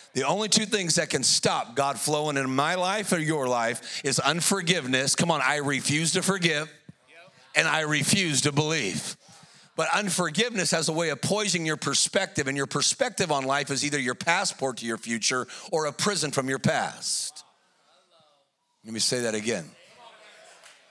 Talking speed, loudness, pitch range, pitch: 170 wpm, -25 LUFS, 135-180 Hz, 150 Hz